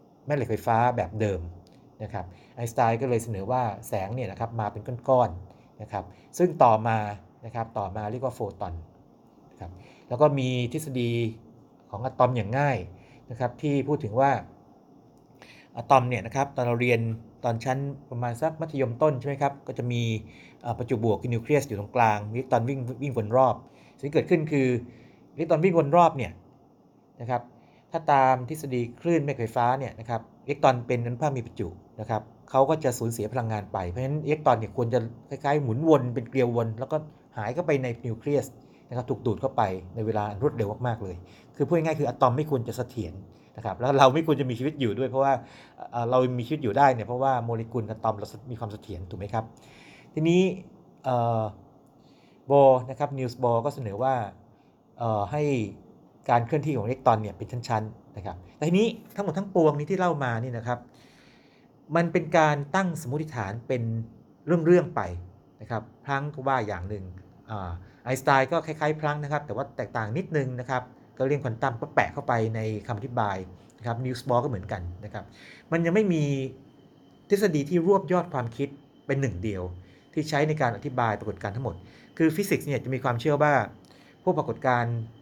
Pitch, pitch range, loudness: 125 Hz, 110-140 Hz, -27 LUFS